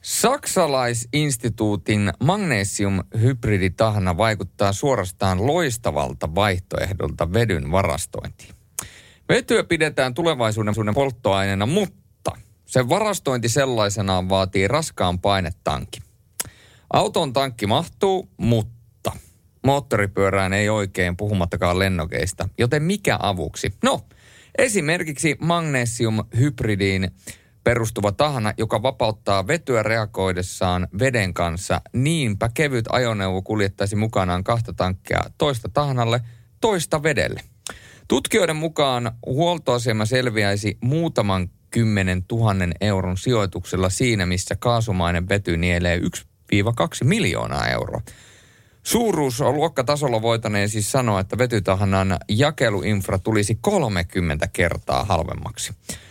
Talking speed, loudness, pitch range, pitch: 90 wpm, -21 LUFS, 95-125 Hz, 105 Hz